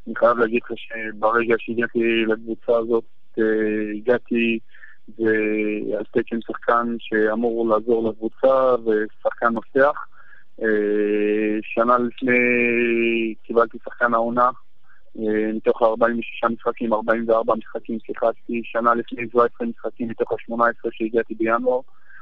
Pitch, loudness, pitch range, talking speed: 115 Hz, -21 LUFS, 110-120 Hz, 95 wpm